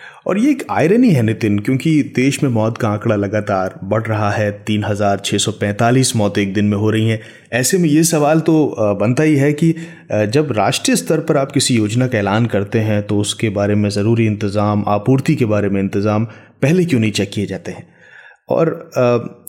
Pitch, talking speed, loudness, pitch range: 110 Hz, 195 wpm, -16 LUFS, 105-135 Hz